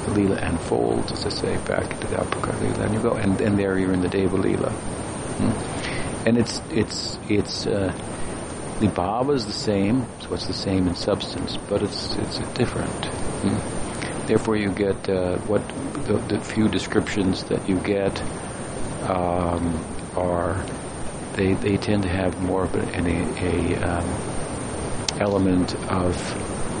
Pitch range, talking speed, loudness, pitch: 90-105 Hz, 155 wpm, -24 LUFS, 95 Hz